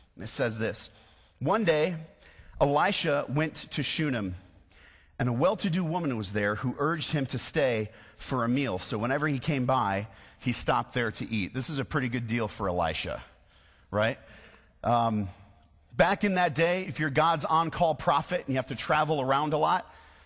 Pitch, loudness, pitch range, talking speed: 130 Hz, -28 LUFS, 105-155 Hz, 185 wpm